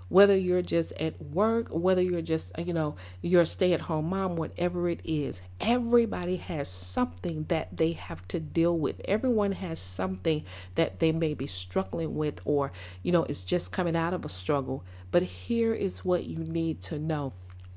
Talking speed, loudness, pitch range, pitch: 180 wpm, -29 LUFS, 145-180 Hz, 165 Hz